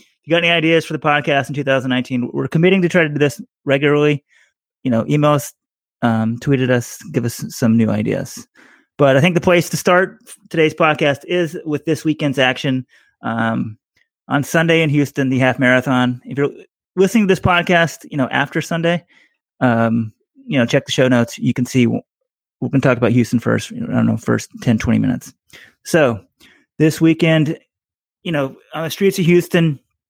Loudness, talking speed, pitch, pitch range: -16 LUFS, 190 wpm, 145 Hz, 125-165 Hz